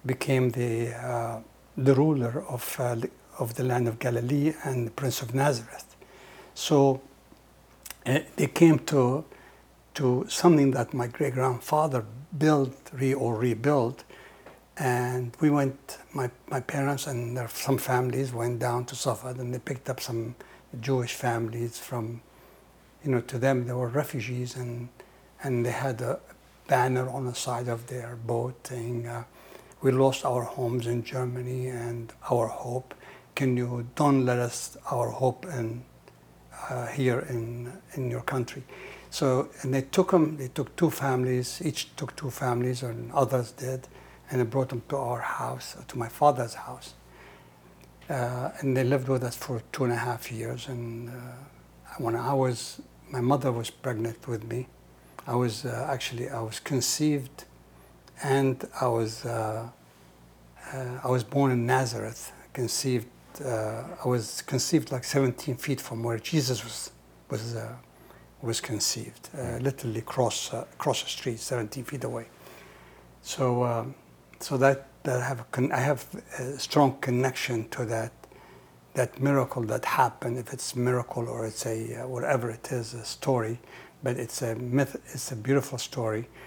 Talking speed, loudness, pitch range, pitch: 160 wpm, -29 LUFS, 120-135 Hz, 125 Hz